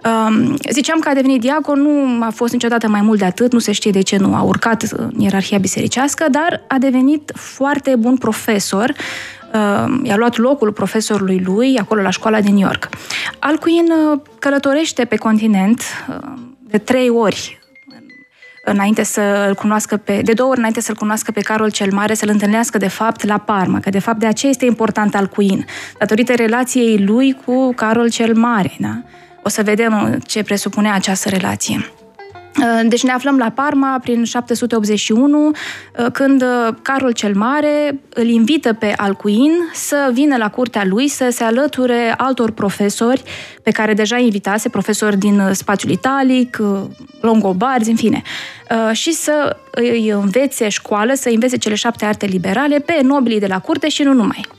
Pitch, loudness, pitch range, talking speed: 230 Hz, -15 LUFS, 210-265 Hz, 160 wpm